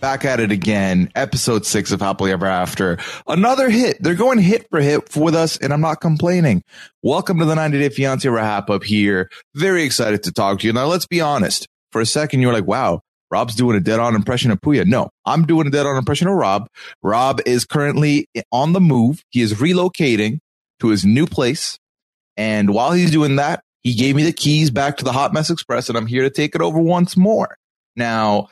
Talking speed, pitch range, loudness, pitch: 215 wpm, 110-165 Hz, -17 LUFS, 140 Hz